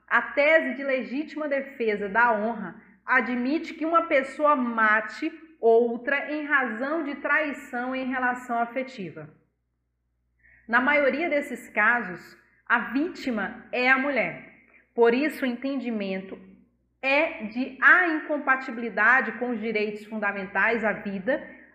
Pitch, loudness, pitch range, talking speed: 250 Hz, -24 LUFS, 220-285 Hz, 120 wpm